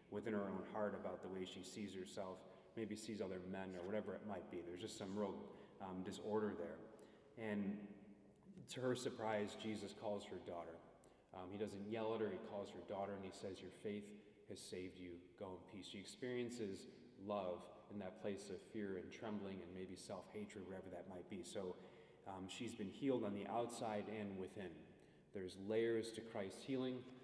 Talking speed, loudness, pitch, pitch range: 195 wpm, -49 LUFS, 100 Hz, 95-110 Hz